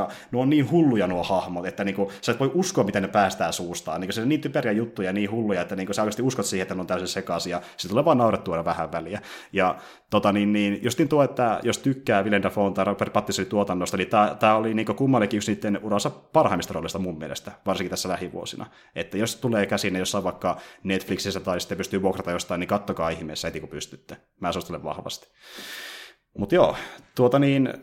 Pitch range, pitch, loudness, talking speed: 90-110 Hz, 100 Hz, -25 LUFS, 205 wpm